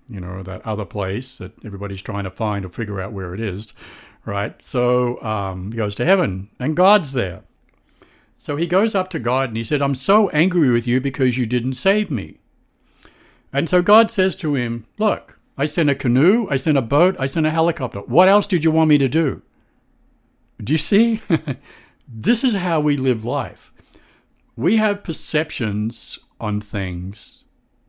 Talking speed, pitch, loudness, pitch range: 185 wpm, 130 Hz, -19 LUFS, 110-165 Hz